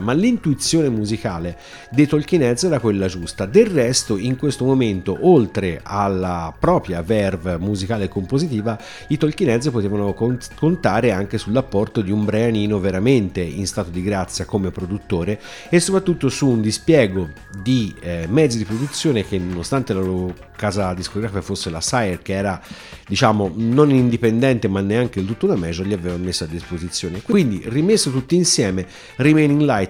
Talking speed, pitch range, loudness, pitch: 155 wpm, 95-130 Hz, -19 LUFS, 105 Hz